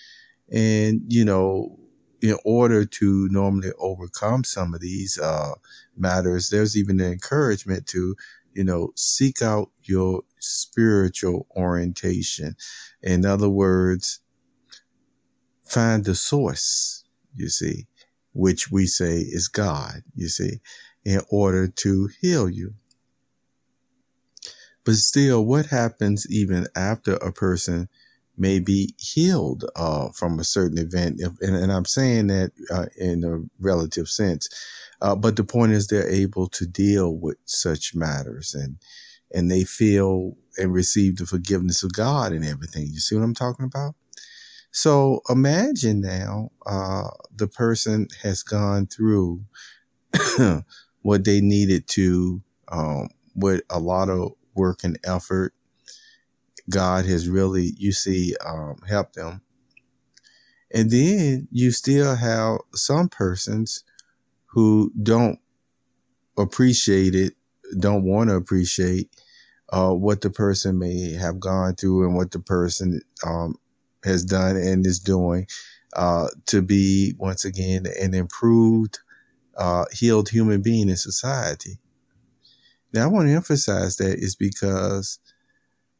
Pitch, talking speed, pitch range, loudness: 95 Hz, 130 wpm, 90-110 Hz, -22 LUFS